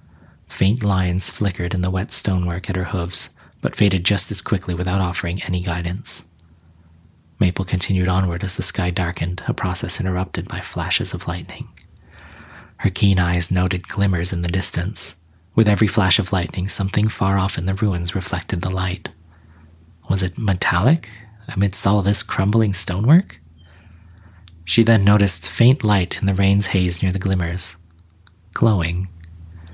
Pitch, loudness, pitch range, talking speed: 95 Hz, -18 LUFS, 85-100 Hz, 155 wpm